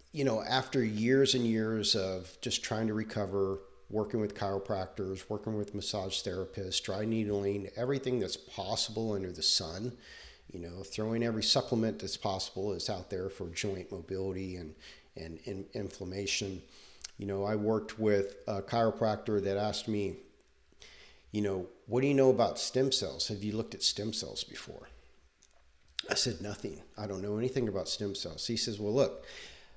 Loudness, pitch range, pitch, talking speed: -33 LUFS, 95-115 Hz, 105 Hz, 165 wpm